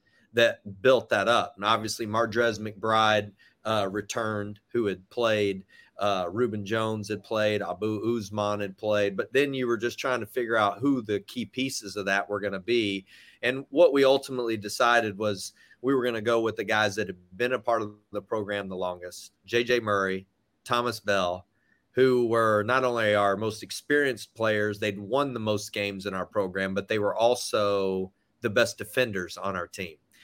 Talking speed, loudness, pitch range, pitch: 190 wpm, -27 LUFS, 100-120 Hz, 110 Hz